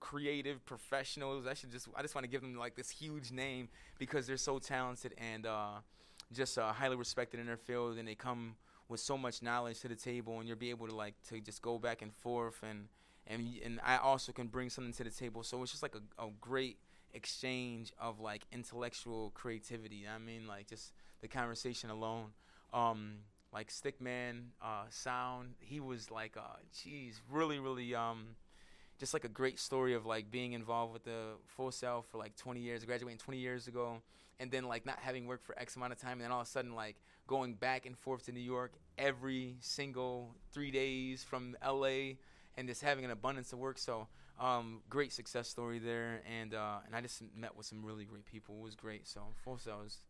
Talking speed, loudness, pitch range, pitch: 215 wpm, -43 LUFS, 115-130 Hz, 120 Hz